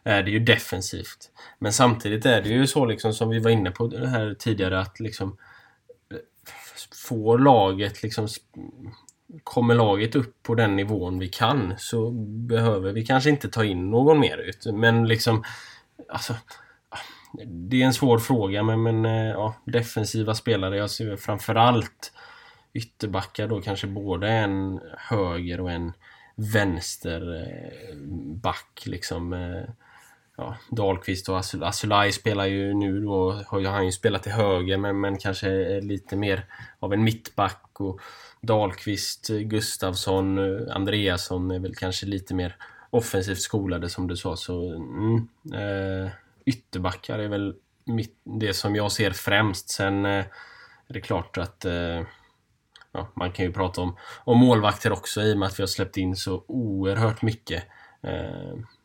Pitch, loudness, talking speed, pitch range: 100 Hz, -25 LUFS, 150 wpm, 95-115 Hz